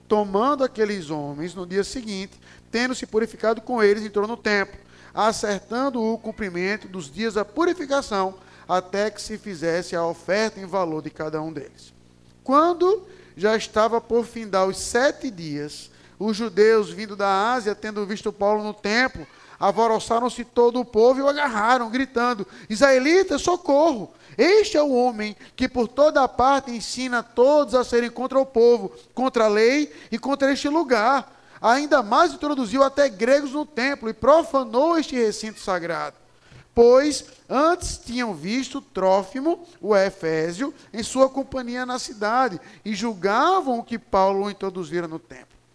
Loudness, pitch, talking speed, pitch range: -22 LUFS, 230 Hz, 150 wpm, 200-265 Hz